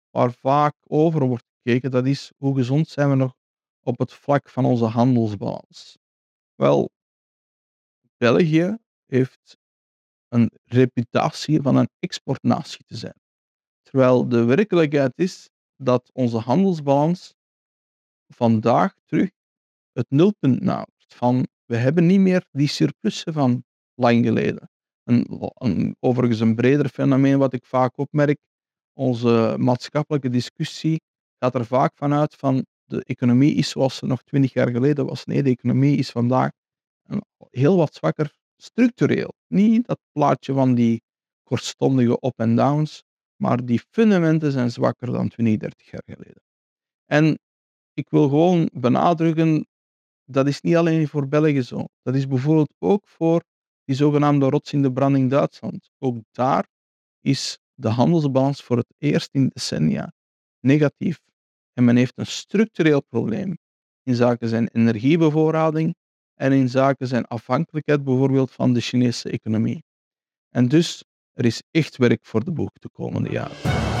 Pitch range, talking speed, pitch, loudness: 120-155 Hz, 140 wpm, 135 Hz, -21 LUFS